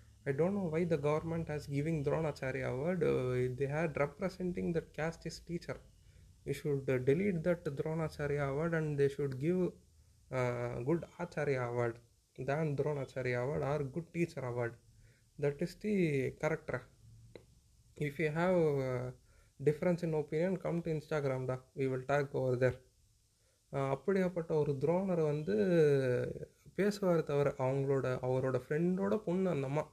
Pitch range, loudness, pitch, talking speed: 130-165 Hz, -35 LUFS, 145 Hz, 135 wpm